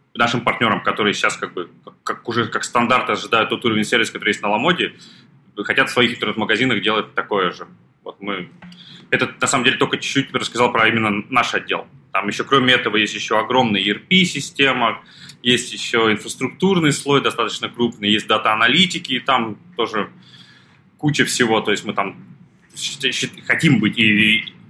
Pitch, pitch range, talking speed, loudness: 125 Hz, 110-140 Hz, 165 wpm, -18 LUFS